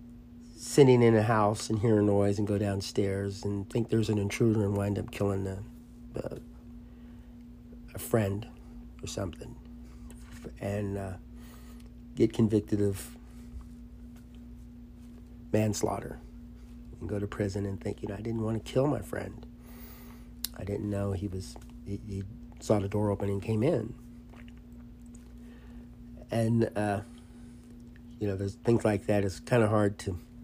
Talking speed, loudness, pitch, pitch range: 145 wpm, -30 LUFS, 105 Hz, 95-120 Hz